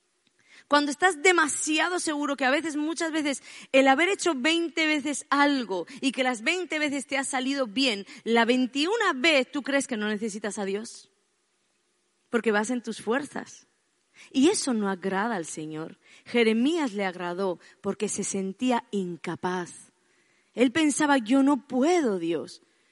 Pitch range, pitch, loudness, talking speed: 210-295 Hz, 260 Hz, -26 LUFS, 150 wpm